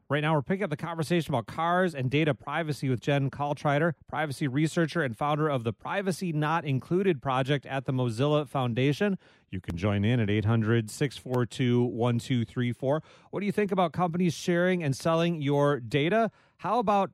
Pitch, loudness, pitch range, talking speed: 145 Hz, -28 LUFS, 130-170 Hz, 170 wpm